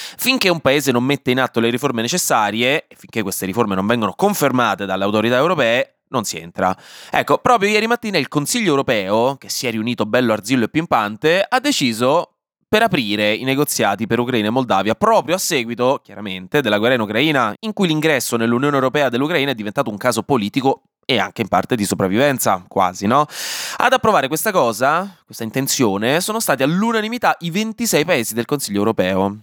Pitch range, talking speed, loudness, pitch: 110-185 Hz, 185 wpm, -17 LUFS, 135 Hz